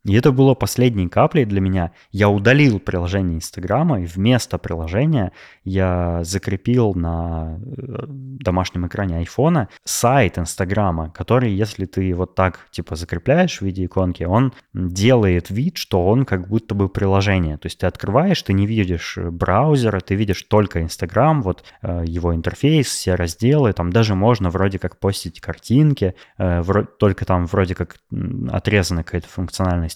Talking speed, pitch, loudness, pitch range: 145 wpm, 95 Hz, -19 LUFS, 90-120 Hz